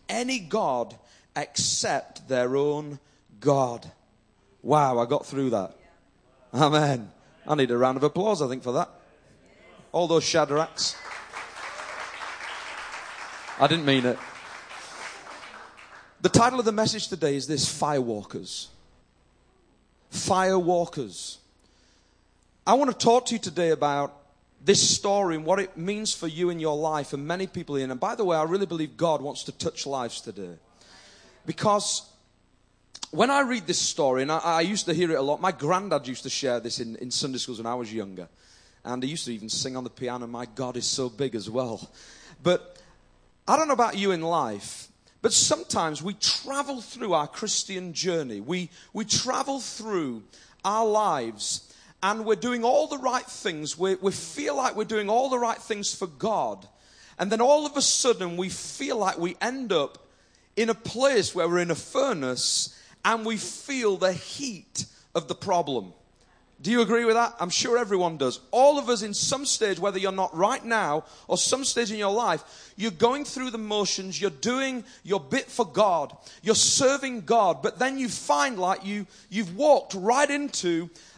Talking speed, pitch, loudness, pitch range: 175 wpm, 180 Hz, -26 LUFS, 140-220 Hz